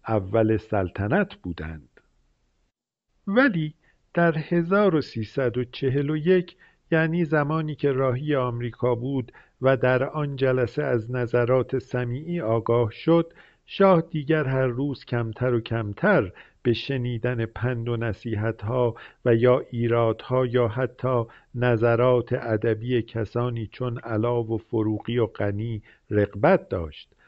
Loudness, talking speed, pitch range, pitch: -24 LUFS, 110 wpm, 115-135 Hz, 125 Hz